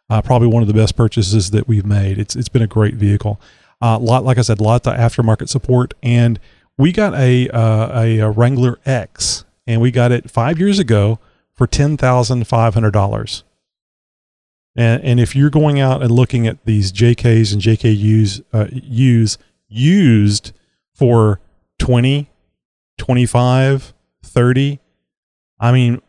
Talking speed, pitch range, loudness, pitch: 150 wpm, 110-125 Hz, -14 LUFS, 115 Hz